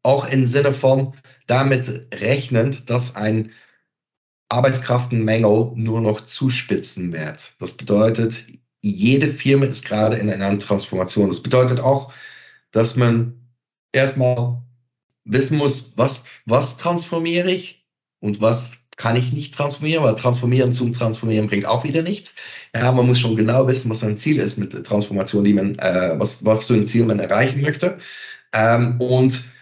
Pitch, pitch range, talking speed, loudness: 125 Hz, 110-135 Hz, 150 wpm, -19 LUFS